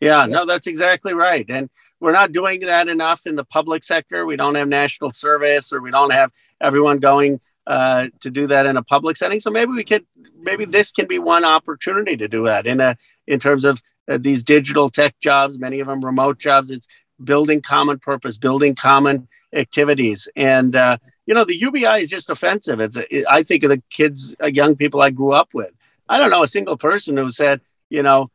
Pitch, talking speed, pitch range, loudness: 145 Hz, 215 wpm, 135-160 Hz, -16 LUFS